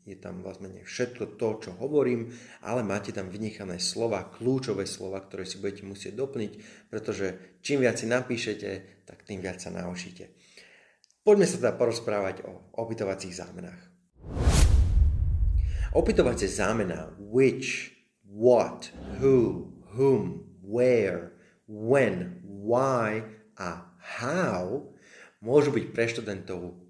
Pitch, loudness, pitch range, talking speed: 105 Hz, -28 LUFS, 95-125 Hz, 115 wpm